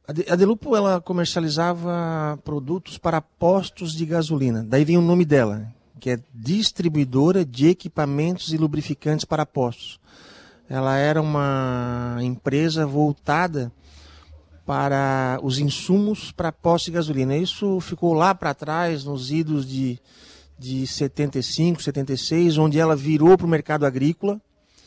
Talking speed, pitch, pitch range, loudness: 130 wpm, 155 Hz, 135-170 Hz, -22 LUFS